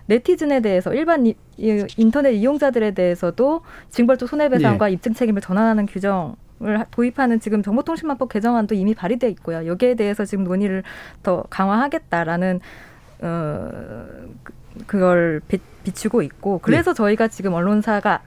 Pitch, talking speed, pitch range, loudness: 215 Hz, 340 characters per minute, 190-240 Hz, -20 LUFS